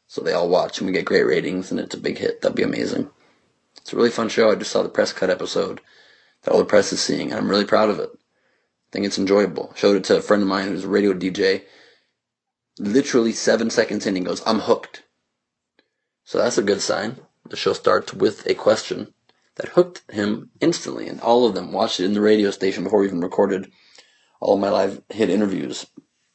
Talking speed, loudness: 225 wpm, -21 LUFS